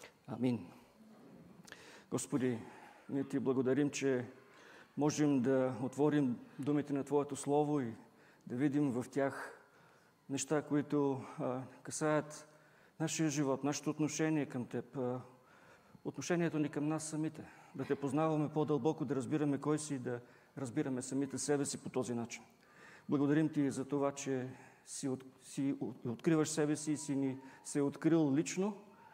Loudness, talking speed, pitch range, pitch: -37 LUFS, 140 wpm, 130-150 Hz, 140 Hz